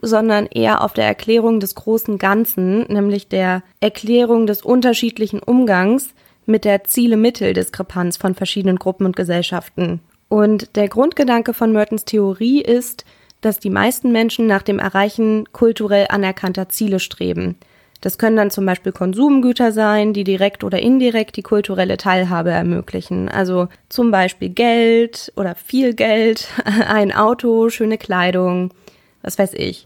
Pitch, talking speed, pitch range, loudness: 210 Hz, 140 wpm, 190-230 Hz, -16 LUFS